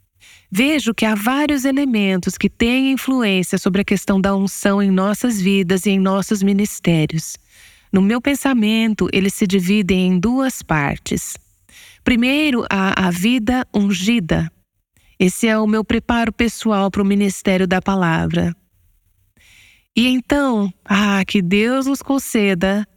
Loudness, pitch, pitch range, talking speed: -17 LUFS, 200 Hz, 190-235 Hz, 135 wpm